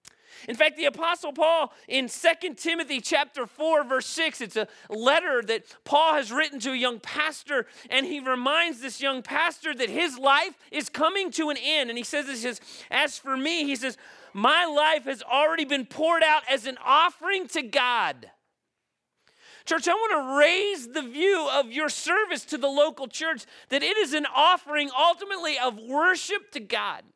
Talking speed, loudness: 185 wpm, -25 LUFS